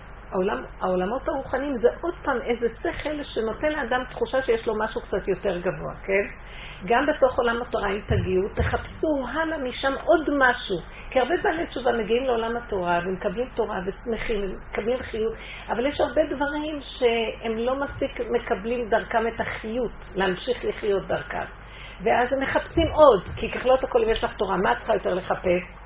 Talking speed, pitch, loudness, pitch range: 165 wpm, 235 Hz, -25 LUFS, 215-270 Hz